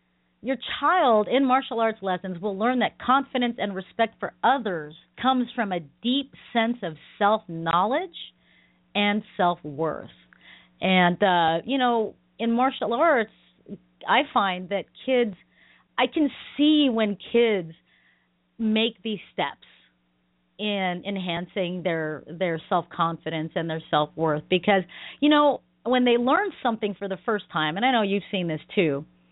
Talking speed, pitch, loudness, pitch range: 145 wpm, 195 Hz, -24 LUFS, 160-235 Hz